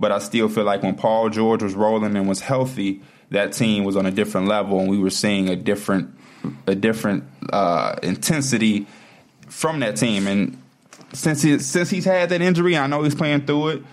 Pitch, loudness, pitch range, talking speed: 110 Hz, -20 LUFS, 100-145 Hz, 205 wpm